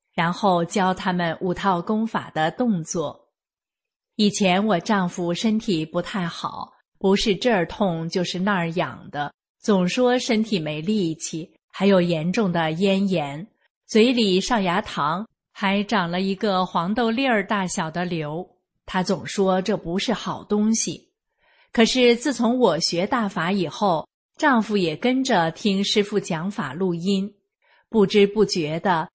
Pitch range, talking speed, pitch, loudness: 175-220 Hz, 210 characters per minute, 195 Hz, -22 LUFS